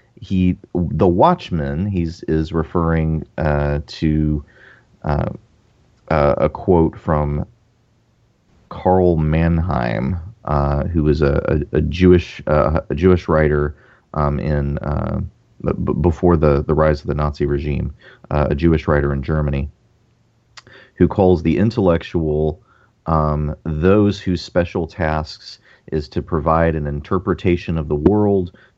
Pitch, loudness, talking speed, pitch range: 80 Hz, -18 LUFS, 125 wpm, 75-90 Hz